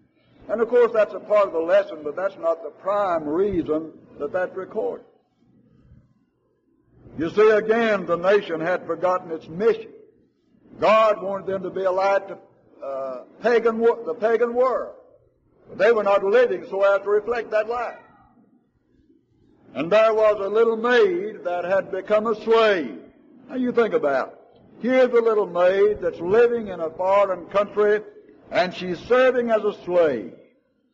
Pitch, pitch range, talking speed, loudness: 215 Hz, 185-240 Hz, 165 wpm, -21 LUFS